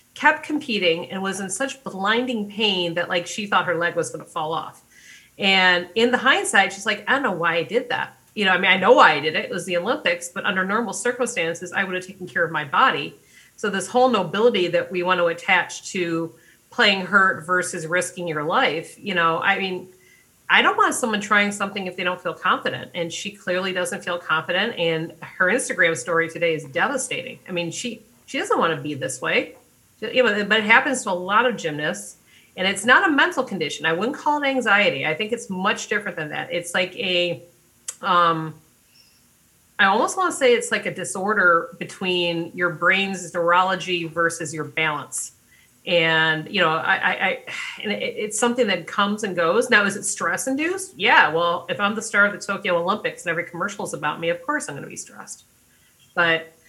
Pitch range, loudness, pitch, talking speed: 170-220 Hz, -21 LUFS, 185 Hz, 215 wpm